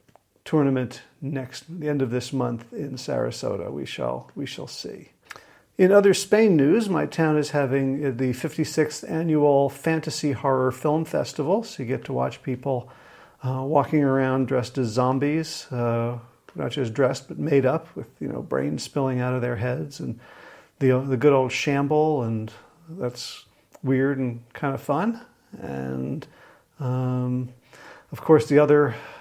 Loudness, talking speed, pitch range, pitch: -24 LUFS, 155 wpm, 125-150 Hz, 135 Hz